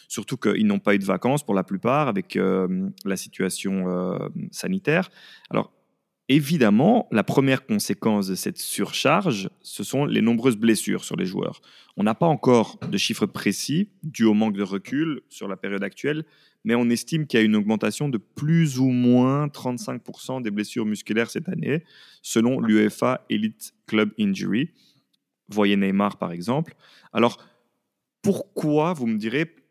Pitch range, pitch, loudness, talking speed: 105-155 Hz, 120 Hz, -23 LUFS, 160 wpm